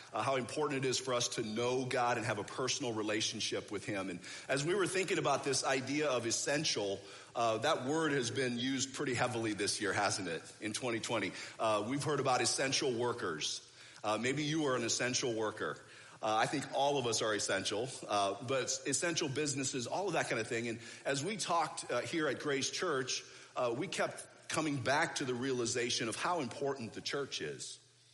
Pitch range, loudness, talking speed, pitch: 115-140 Hz, -35 LUFS, 205 wpm, 125 Hz